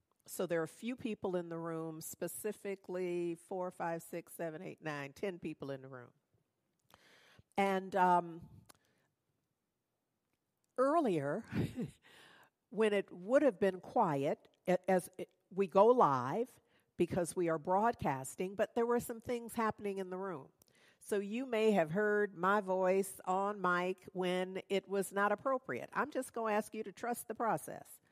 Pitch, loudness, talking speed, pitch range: 190 Hz, -36 LUFS, 155 wpm, 170-215 Hz